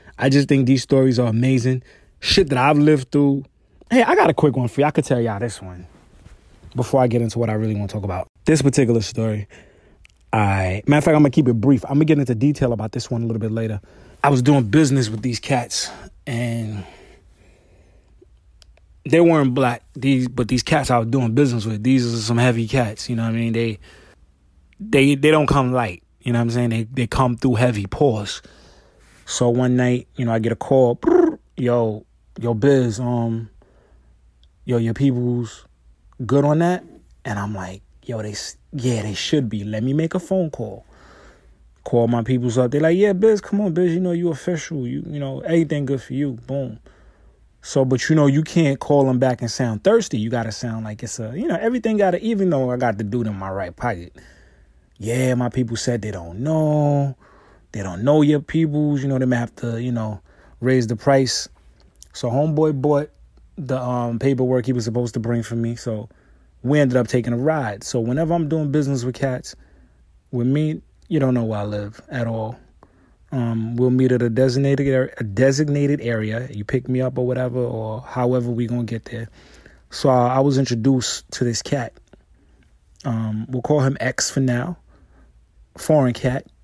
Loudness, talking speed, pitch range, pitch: -20 LUFS, 210 wpm, 110-140 Hz, 125 Hz